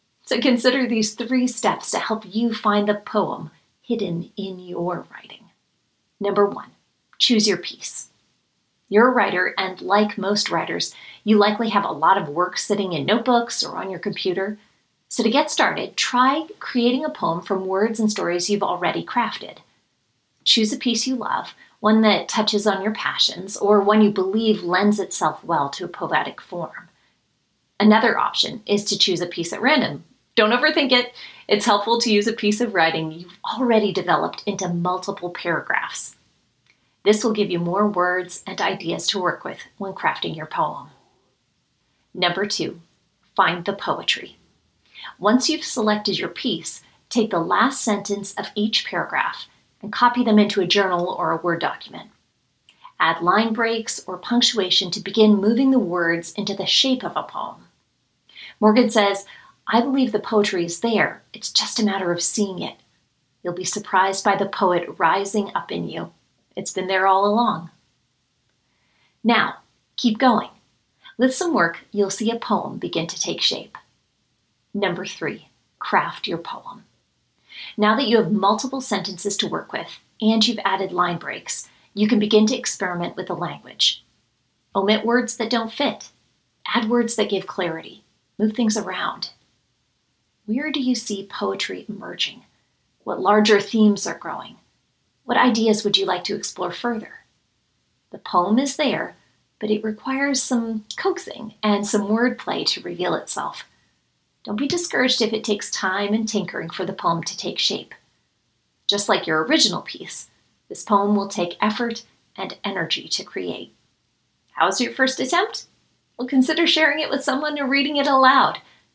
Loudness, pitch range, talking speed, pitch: -21 LUFS, 190-235 Hz, 165 wpm, 210 Hz